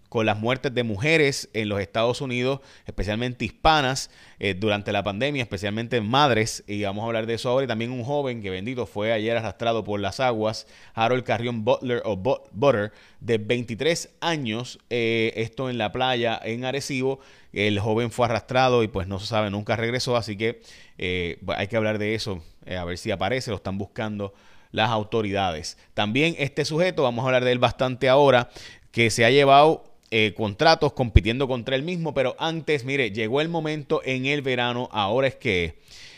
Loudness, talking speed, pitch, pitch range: -24 LUFS, 185 wpm, 115 Hz, 105-130 Hz